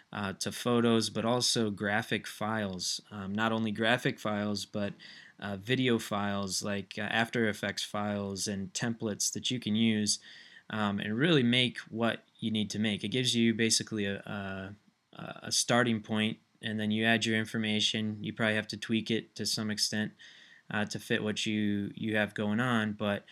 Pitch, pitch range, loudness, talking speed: 110 Hz, 105-115 Hz, -31 LUFS, 180 wpm